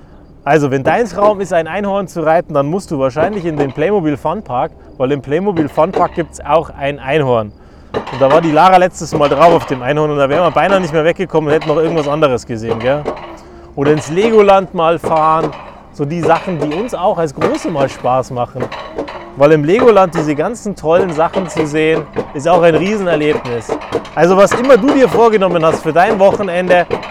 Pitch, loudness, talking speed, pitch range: 160 Hz, -13 LUFS, 200 wpm, 145-185 Hz